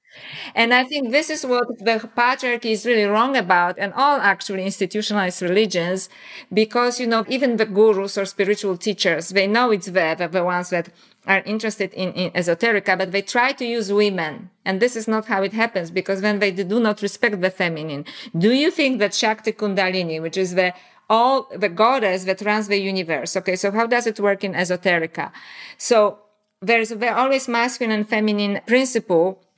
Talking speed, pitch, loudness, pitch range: 185 wpm, 205 Hz, -19 LUFS, 185-230 Hz